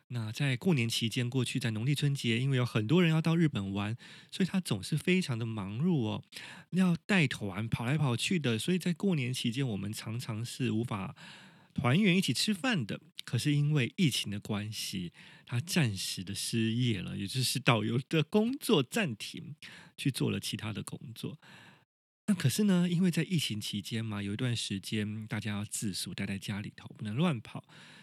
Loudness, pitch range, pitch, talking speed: -32 LUFS, 110-170 Hz, 130 Hz, 275 characters per minute